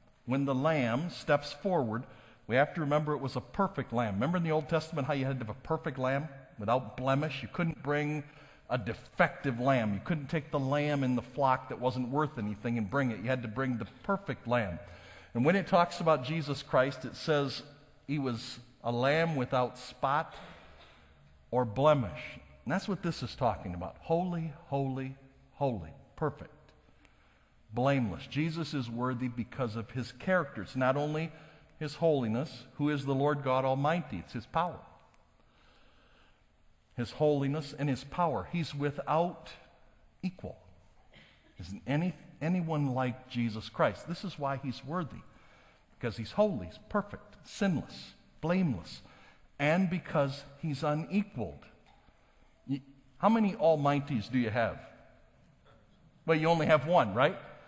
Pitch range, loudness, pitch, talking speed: 120-155 Hz, -32 LUFS, 140 Hz, 155 wpm